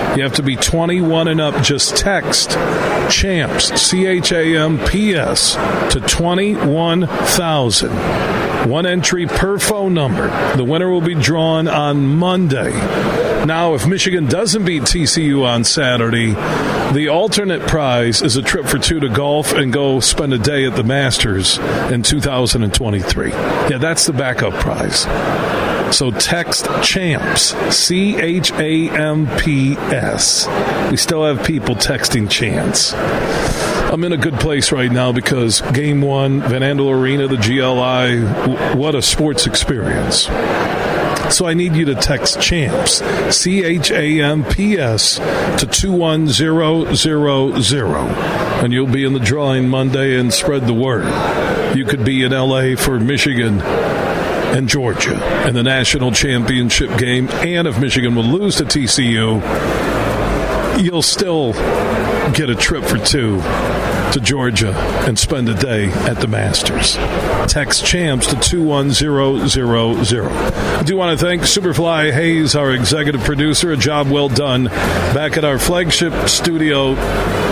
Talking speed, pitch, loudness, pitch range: 140 wpm, 140 Hz, -14 LUFS, 125-160 Hz